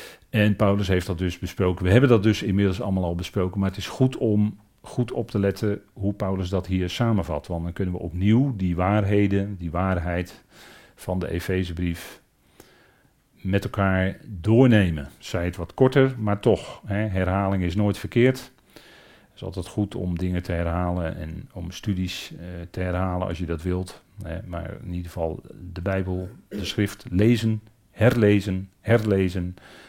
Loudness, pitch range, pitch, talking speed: -24 LUFS, 90-105 Hz, 95 Hz, 170 wpm